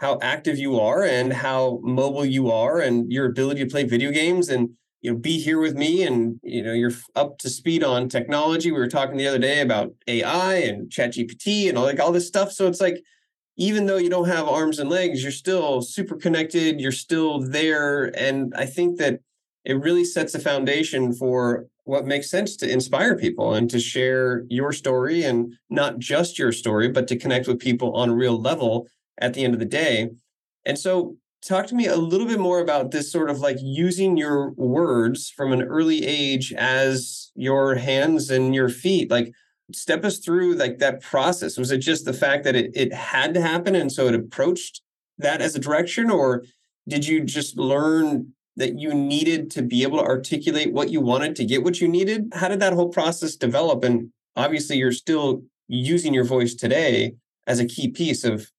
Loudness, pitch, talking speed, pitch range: -22 LUFS, 140 Hz, 205 wpm, 125-170 Hz